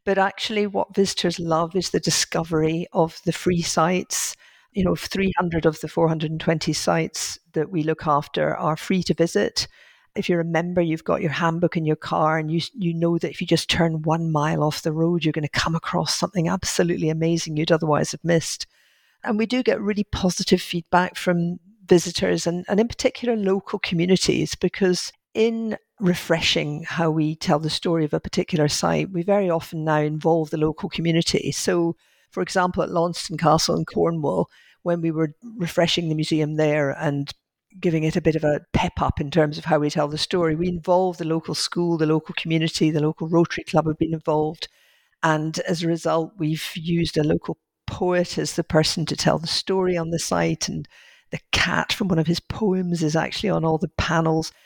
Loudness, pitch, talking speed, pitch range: -22 LUFS, 165 Hz, 195 wpm, 155-180 Hz